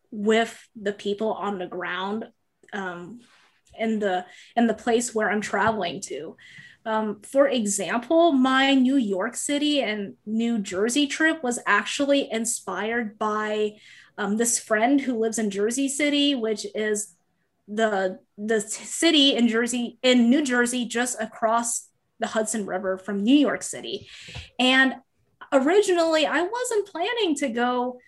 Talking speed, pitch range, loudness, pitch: 140 wpm, 210-265 Hz, -23 LUFS, 230 Hz